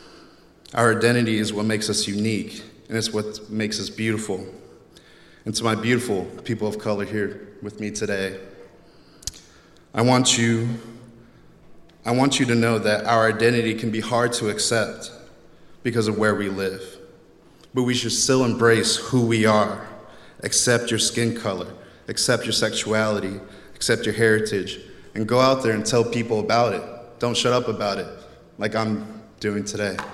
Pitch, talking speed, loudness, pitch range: 110 Hz, 160 wpm, -22 LUFS, 105-120 Hz